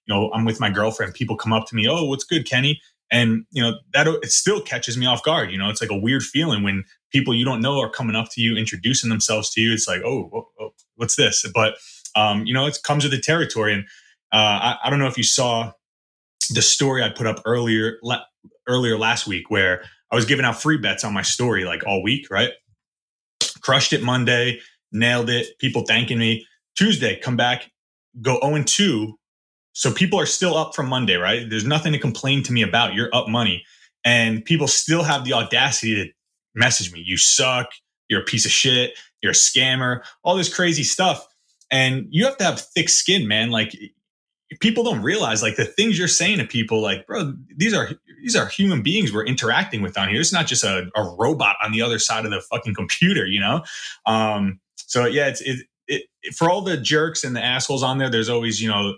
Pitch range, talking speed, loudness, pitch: 110-145 Hz, 220 wpm, -19 LUFS, 120 Hz